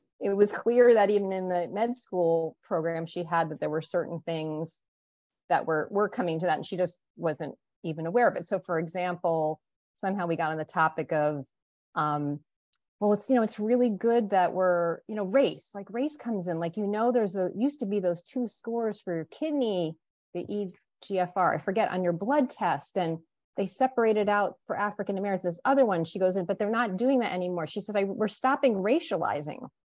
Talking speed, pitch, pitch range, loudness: 210 wpm, 190 Hz, 170-220 Hz, -28 LUFS